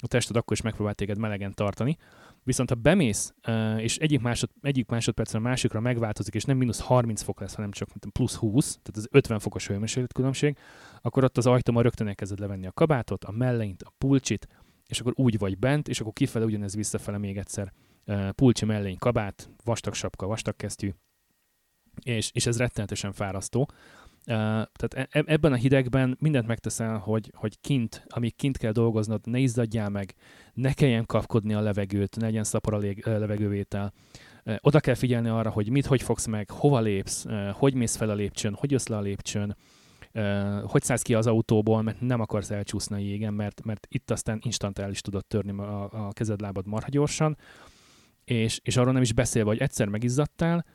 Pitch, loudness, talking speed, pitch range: 110 Hz, -27 LUFS, 185 wpm, 105-125 Hz